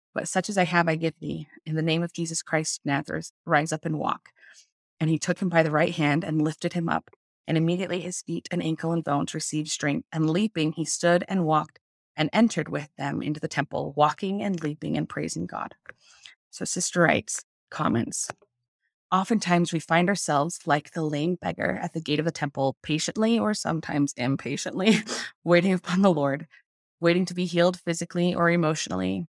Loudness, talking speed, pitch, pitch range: -26 LUFS, 190 wpm, 165 Hz, 150-175 Hz